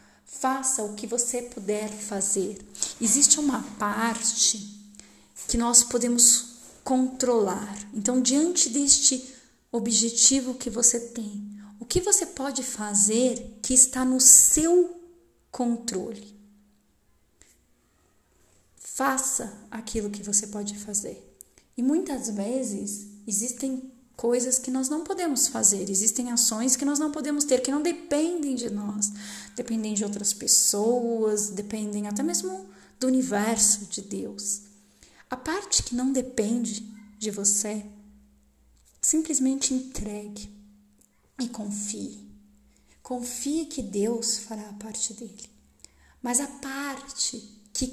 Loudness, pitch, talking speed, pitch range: -23 LUFS, 230 Hz, 115 wpm, 205-260 Hz